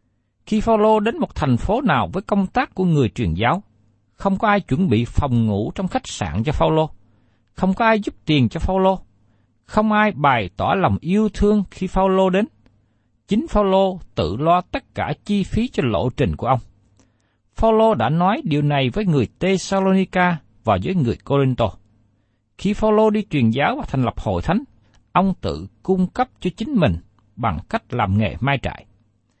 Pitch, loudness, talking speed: 145 Hz, -20 LUFS, 200 wpm